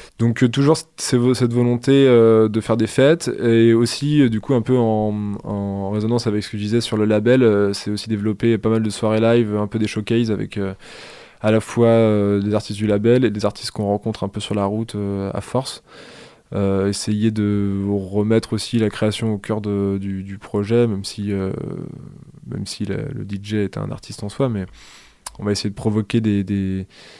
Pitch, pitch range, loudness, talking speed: 110 Hz, 100-120 Hz, -19 LUFS, 220 wpm